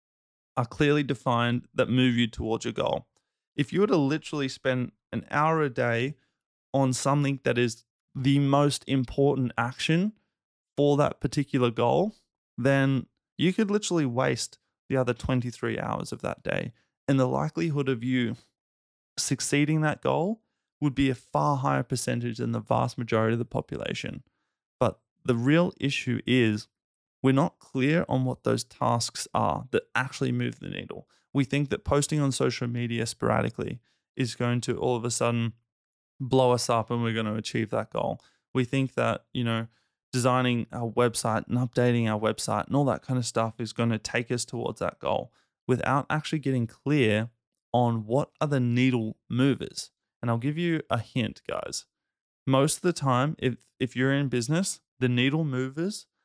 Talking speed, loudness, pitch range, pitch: 175 wpm, -27 LUFS, 120-140 Hz, 130 Hz